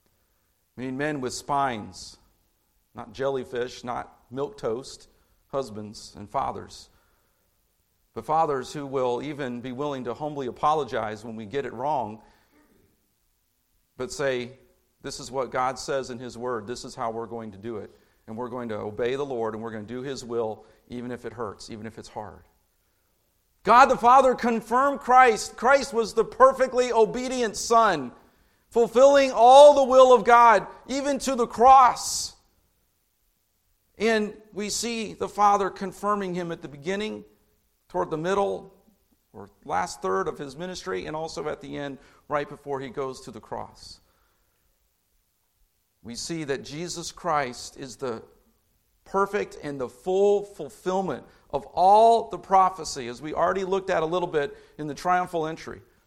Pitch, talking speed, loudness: 140 Hz, 160 wpm, -24 LUFS